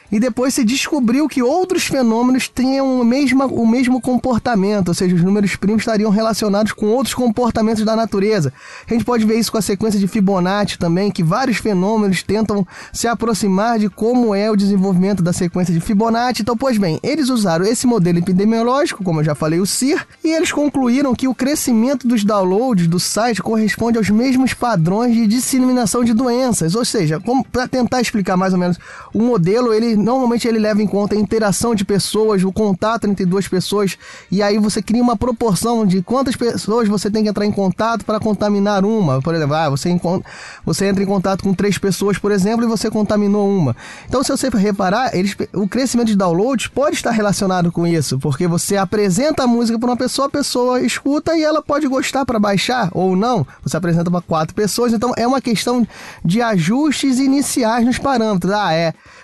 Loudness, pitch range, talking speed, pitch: -16 LUFS, 195-245 Hz, 195 wpm, 220 Hz